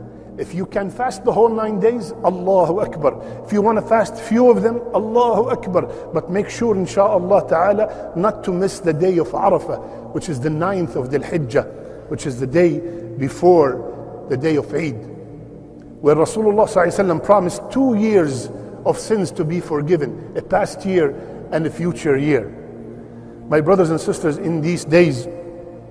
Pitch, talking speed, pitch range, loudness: 175 Hz, 165 wpm, 160-205 Hz, -18 LUFS